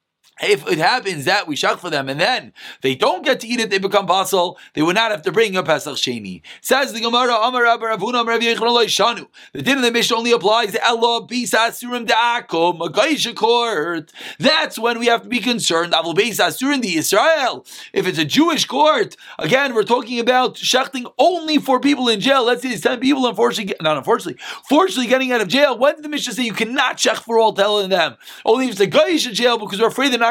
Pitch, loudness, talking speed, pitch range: 235 Hz, -17 LUFS, 215 wpm, 210-260 Hz